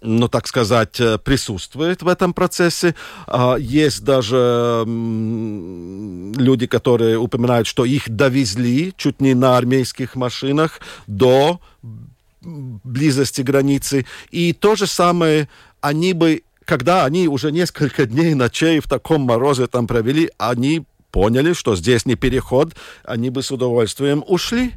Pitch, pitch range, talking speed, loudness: 135 Hz, 120-155 Hz, 125 wpm, -17 LUFS